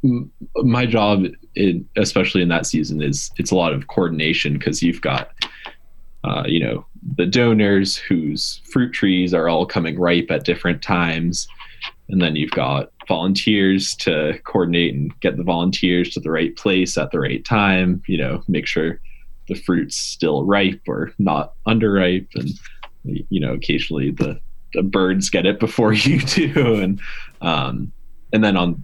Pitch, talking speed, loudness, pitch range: 95 Hz, 160 wpm, -19 LUFS, 85-105 Hz